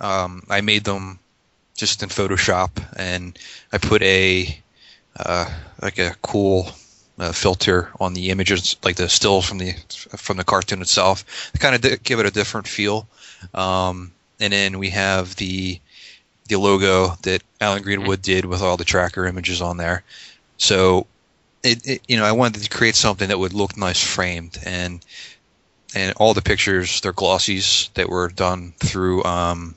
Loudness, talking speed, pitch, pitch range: -19 LUFS, 170 wpm, 95 Hz, 90-100 Hz